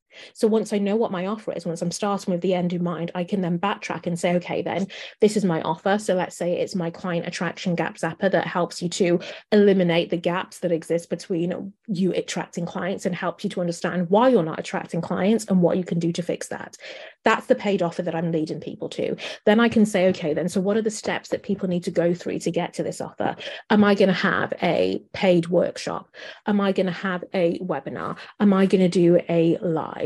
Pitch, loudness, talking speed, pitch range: 180 Hz, -23 LUFS, 240 wpm, 175-200 Hz